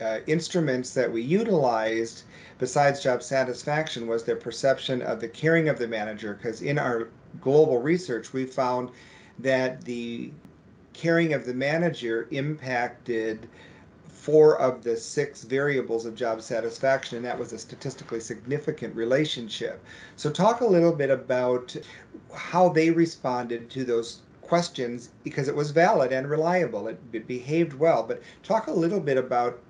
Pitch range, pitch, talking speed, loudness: 120-150 Hz, 130 Hz, 150 wpm, -26 LUFS